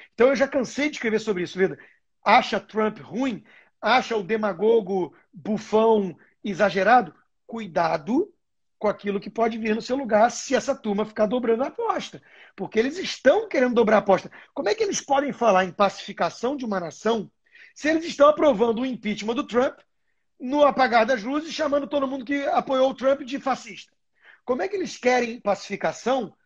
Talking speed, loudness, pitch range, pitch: 180 wpm, -23 LUFS, 210-275 Hz, 235 Hz